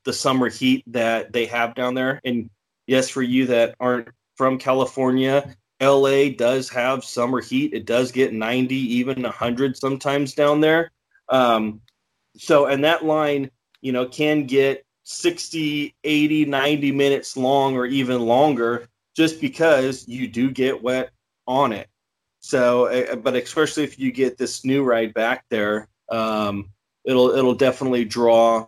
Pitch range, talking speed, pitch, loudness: 120-140 Hz, 150 wpm, 130 Hz, -20 LUFS